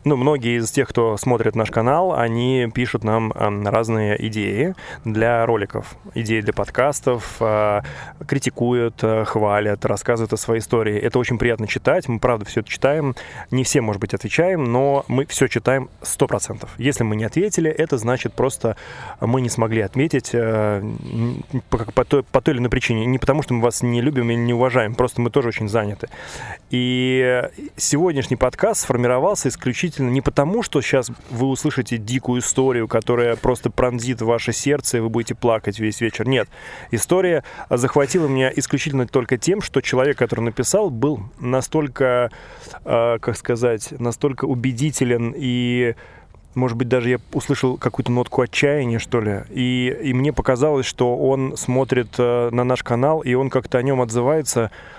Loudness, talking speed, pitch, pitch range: -20 LUFS, 155 wpm, 125 Hz, 115-135 Hz